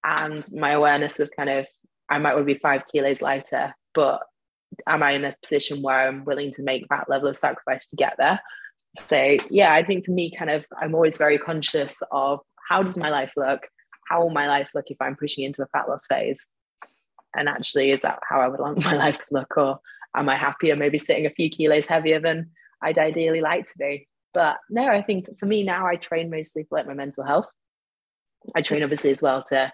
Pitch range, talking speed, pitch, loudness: 140-160 Hz, 230 wpm, 150 Hz, -23 LUFS